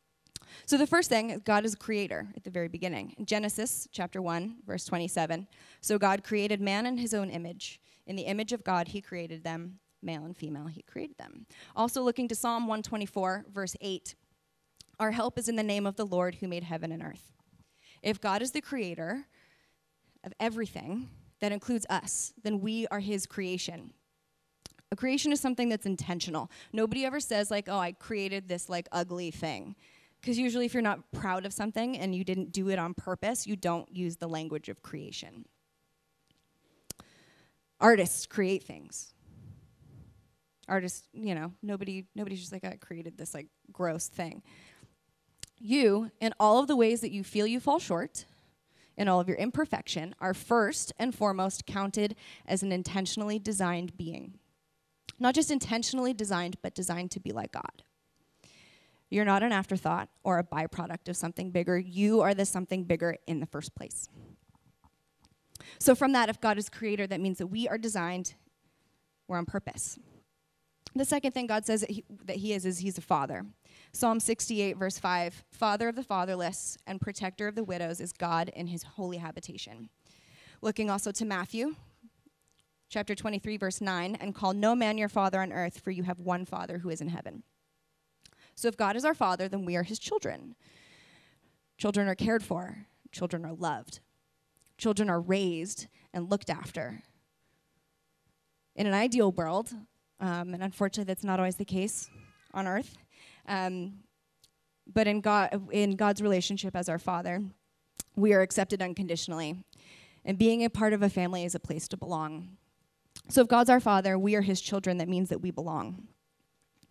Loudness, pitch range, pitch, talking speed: -31 LUFS, 175-215 Hz, 195 Hz, 175 wpm